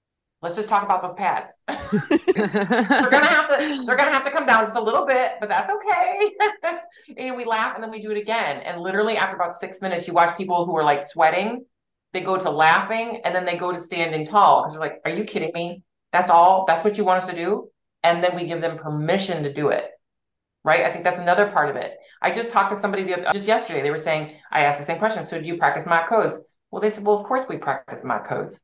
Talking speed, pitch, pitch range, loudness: 260 wpm, 190 Hz, 170-230 Hz, -21 LUFS